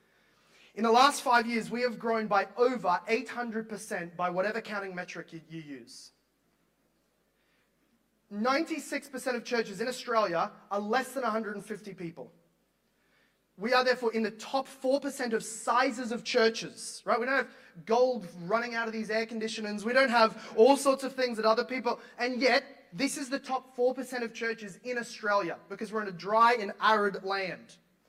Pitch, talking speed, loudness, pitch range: 230 Hz, 165 wpm, -30 LUFS, 210-250 Hz